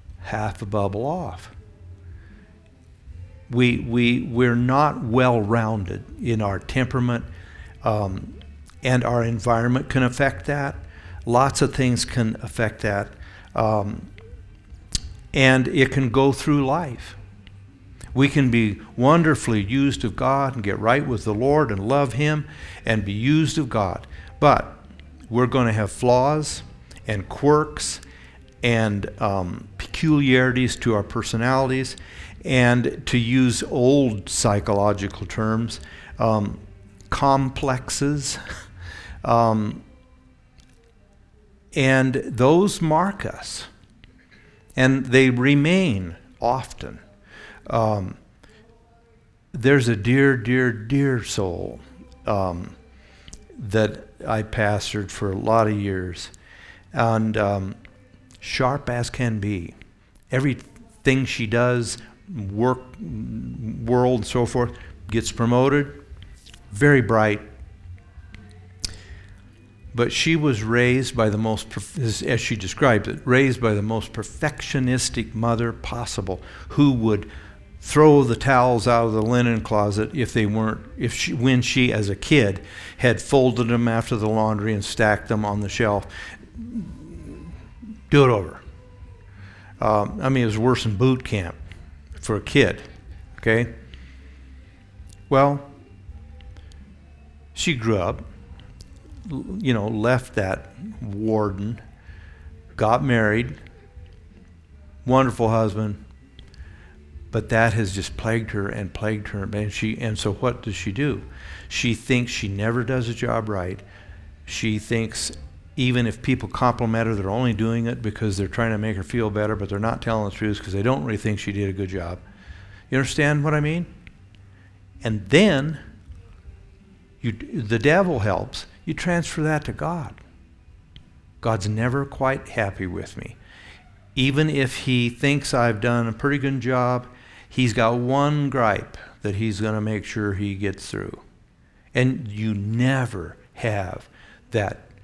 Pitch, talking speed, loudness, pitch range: 110 Hz, 125 wpm, -22 LUFS, 95-125 Hz